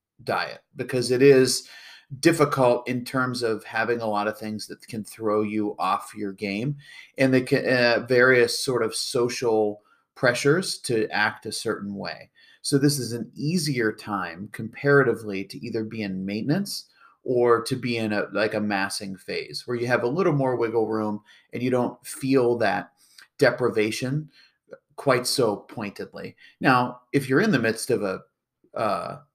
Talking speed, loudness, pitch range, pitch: 165 wpm, -24 LUFS, 110-135 Hz, 120 Hz